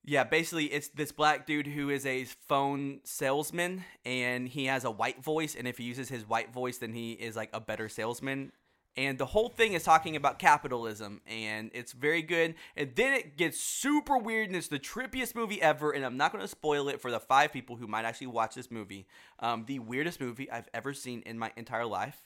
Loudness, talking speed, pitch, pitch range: -32 LUFS, 225 wpm, 135 Hz, 115-150 Hz